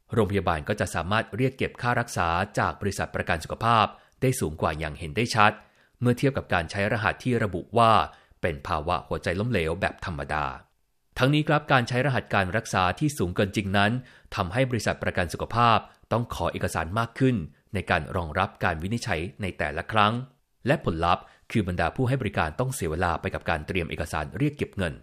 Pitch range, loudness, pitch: 90-120 Hz, -26 LUFS, 100 Hz